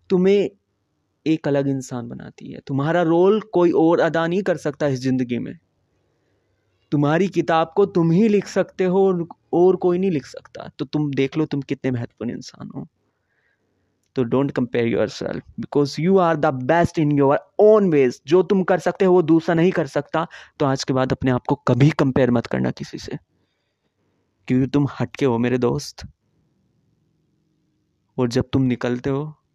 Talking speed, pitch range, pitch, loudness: 180 wpm, 130-175 Hz, 150 Hz, -20 LUFS